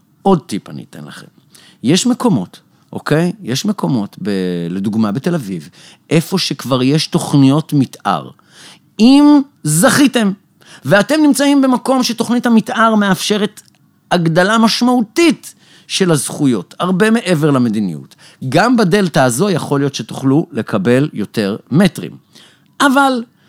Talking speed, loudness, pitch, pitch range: 110 wpm, -13 LUFS, 180 Hz, 145-230 Hz